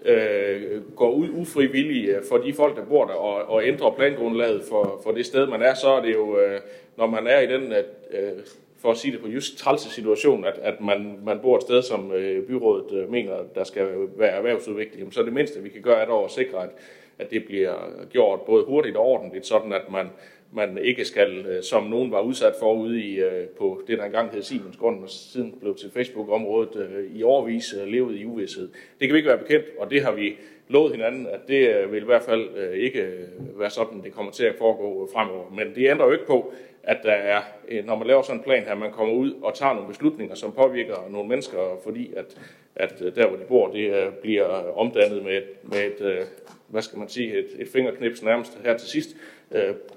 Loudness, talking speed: -23 LUFS, 215 wpm